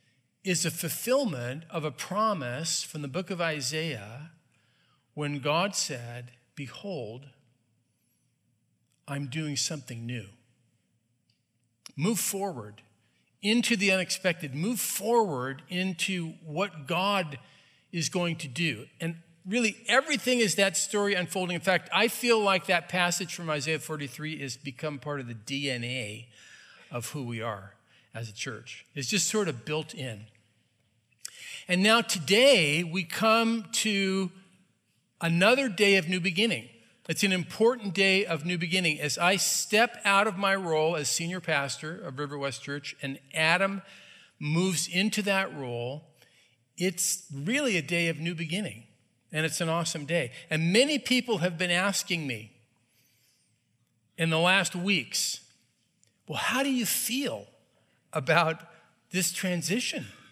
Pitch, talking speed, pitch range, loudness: 165 Hz, 135 wpm, 135-195 Hz, -28 LUFS